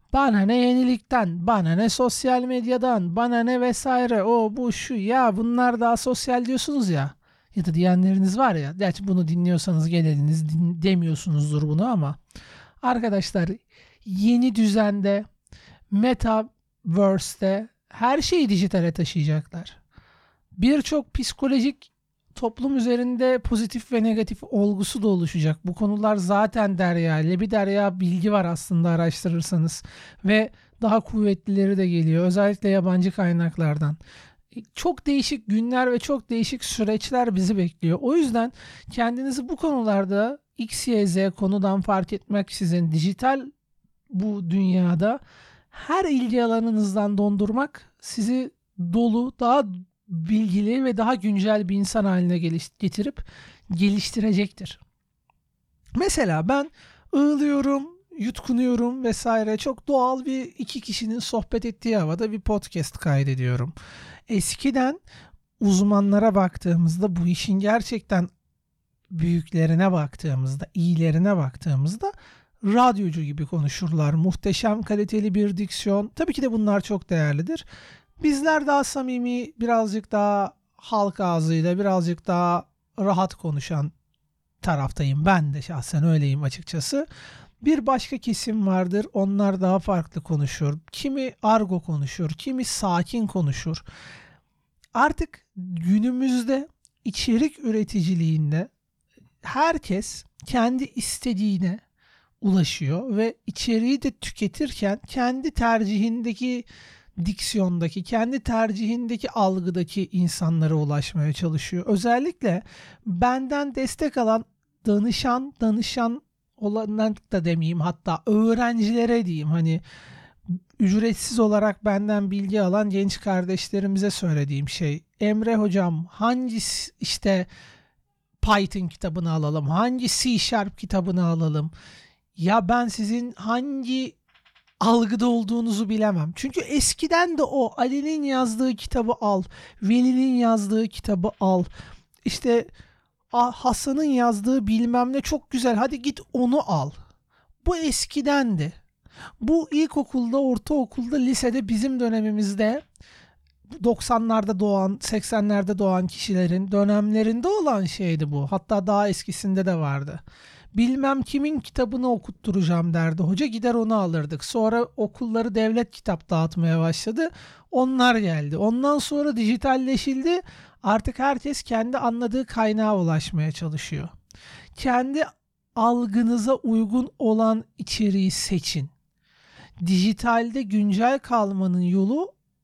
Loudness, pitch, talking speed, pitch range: -23 LUFS, 210 Hz, 105 wpm, 180-245 Hz